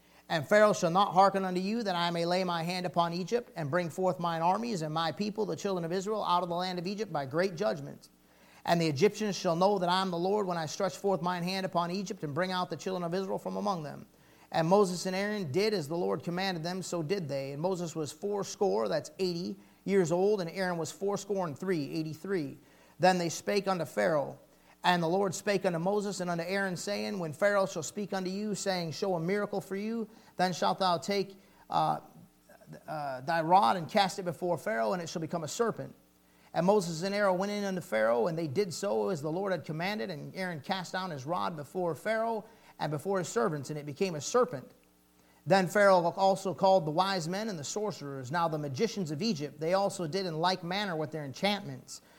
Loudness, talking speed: -31 LUFS, 225 wpm